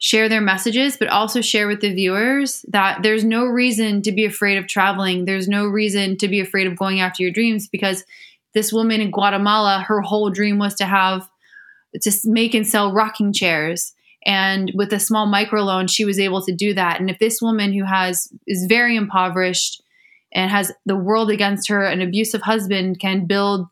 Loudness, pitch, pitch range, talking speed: -18 LUFS, 205 Hz, 190-220 Hz, 195 wpm